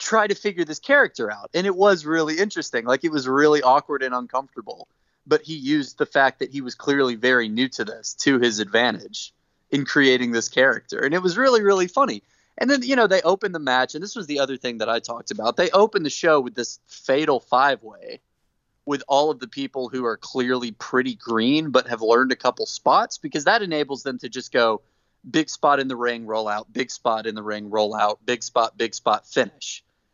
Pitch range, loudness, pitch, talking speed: 120-165 Hz, -21 LUFS, 135 Hz, 225 wpm